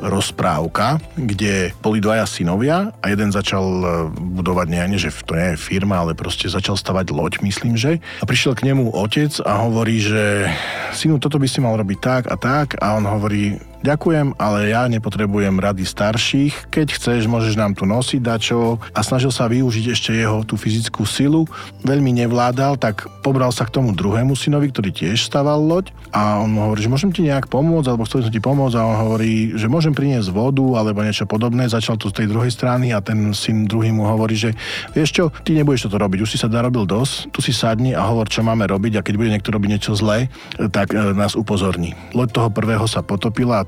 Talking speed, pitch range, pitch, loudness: 205 wpm, 105-130 Hz, 110 Hz, -18 LUFS